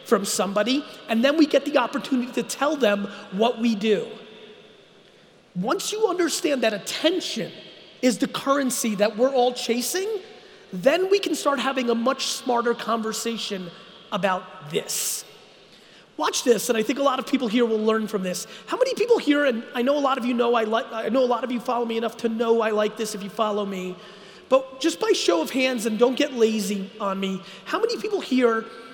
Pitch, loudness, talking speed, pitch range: 240 Hz, -23 LUFS, 205 wpm, 220-275 Hz